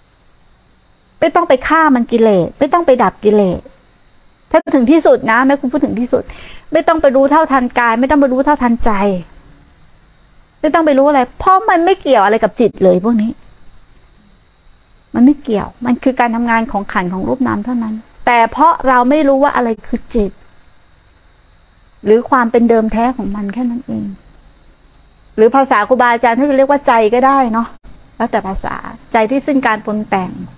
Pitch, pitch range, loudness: 240 Hz, 220-275 Hz, -12 LUFS